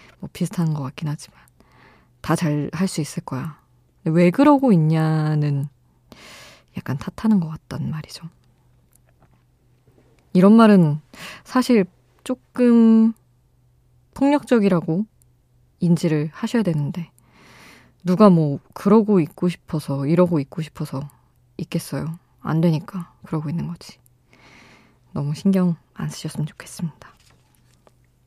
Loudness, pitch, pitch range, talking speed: -20 LUFS, 160 Hz, 130-185 Hz, 225 characters per minute